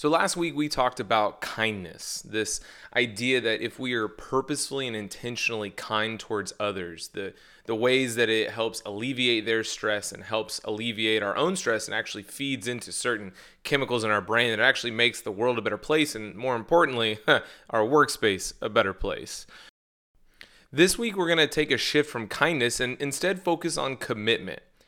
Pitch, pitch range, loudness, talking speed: 120 Hz, 110-135 Hz, -26 LUFS, 180 wpm